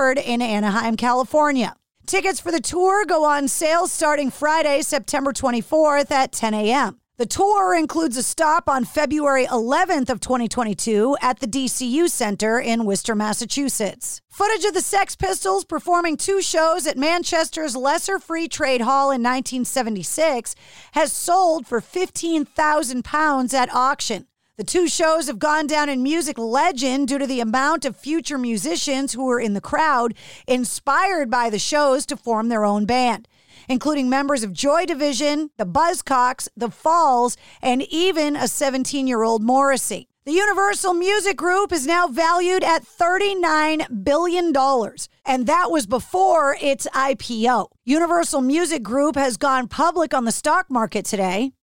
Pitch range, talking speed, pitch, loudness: 250-330 Hz, 150 wpm, 285 Hz, -20 LUFS